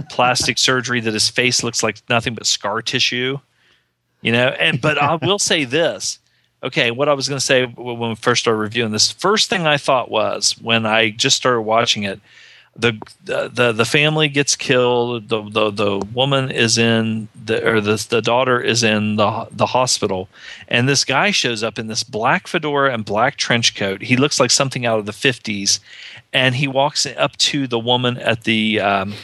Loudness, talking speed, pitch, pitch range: -17 LUFS, 195 wpm, 120 Hz, 110-135 Hz